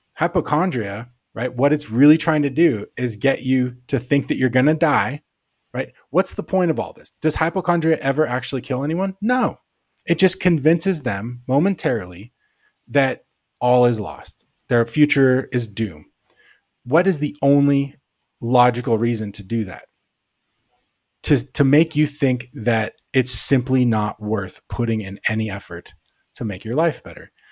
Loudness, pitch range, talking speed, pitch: -20 LUFS, 115-155 Hz, 160 wpm, 130 Hz